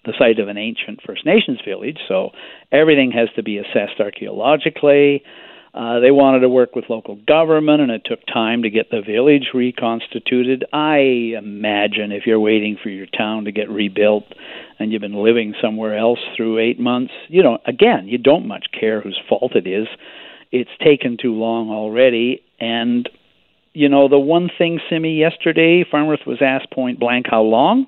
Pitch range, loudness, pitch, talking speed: 110-140 Hz, -16 LUFS, 120 Hz, 180 wpm